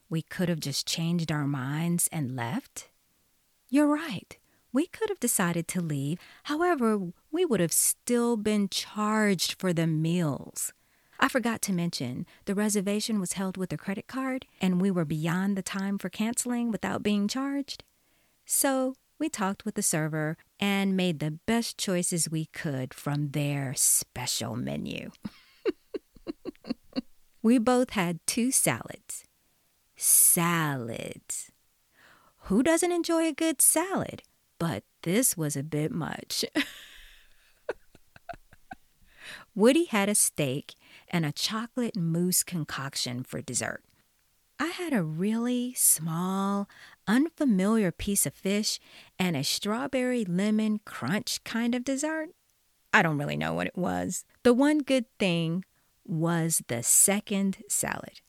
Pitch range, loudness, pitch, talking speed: 165-245 Hz, -27 LUFS, 195 Hz, 130 wpm